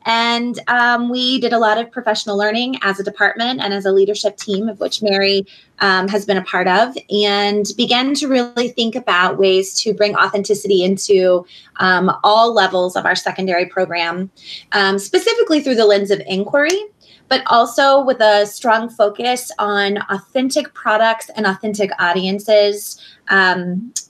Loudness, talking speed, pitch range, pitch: -15 LUFS, 160 wpm, 195-235 Hz, 205 Hz